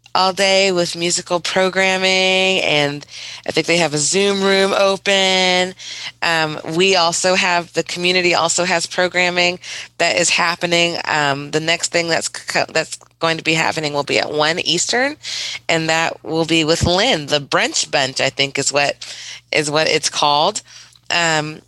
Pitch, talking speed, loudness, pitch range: 170 Hz, 165 wpm, -16 LUFS, 155-185 Hz